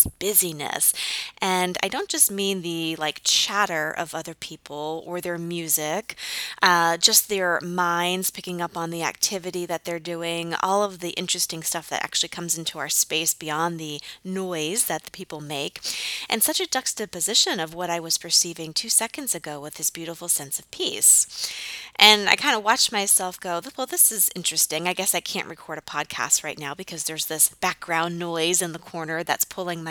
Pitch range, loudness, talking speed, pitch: 160-190 Hz, -22 LUFS, 190 wpm, 175 Hz